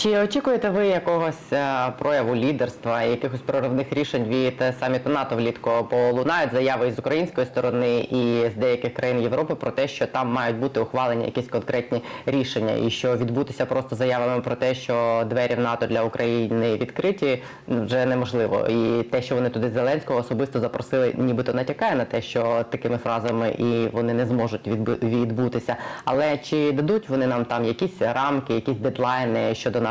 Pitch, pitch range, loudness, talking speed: 125 Hz, 115-135 Hz, -23 LUFS, 165 wpm